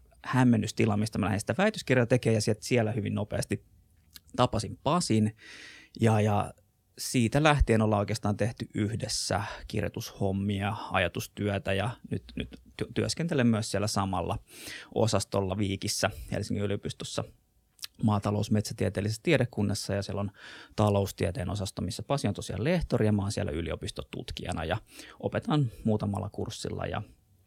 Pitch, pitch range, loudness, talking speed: 105 Hz, 100-115 Hz, -30 LUFS, 125 wpm